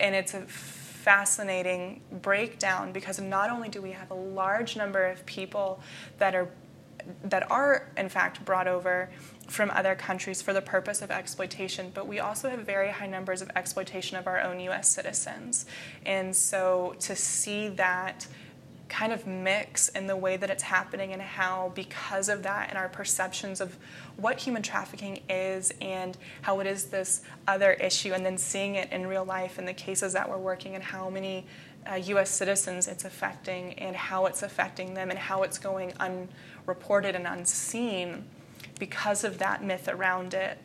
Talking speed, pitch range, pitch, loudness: 175 wpm, 185-195 Hz, 190 Hz, -29 LUFS